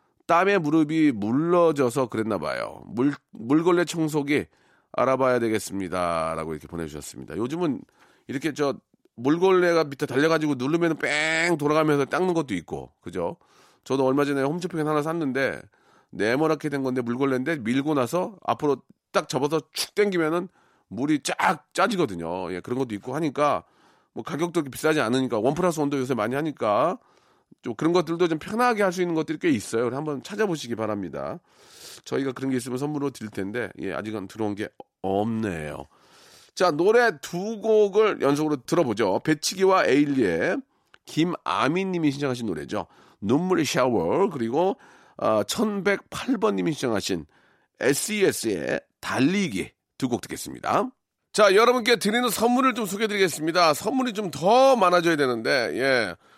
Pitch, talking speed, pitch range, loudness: 150 Hz, 340 characters per minute, 130-180 Hz, -24 LUFS